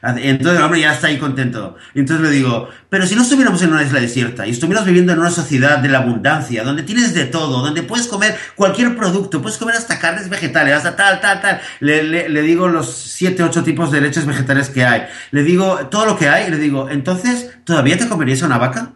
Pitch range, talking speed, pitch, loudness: 140-190 Hz, 230 wpm, 160 Hz, -14 LUFS